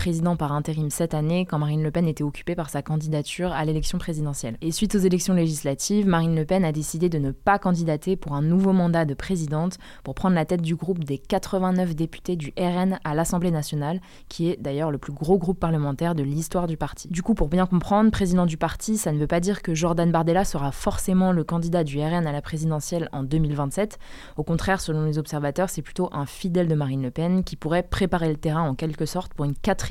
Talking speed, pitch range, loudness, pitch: 230 wpm, 155-180 Hz, -24 LUFS, 165 Hz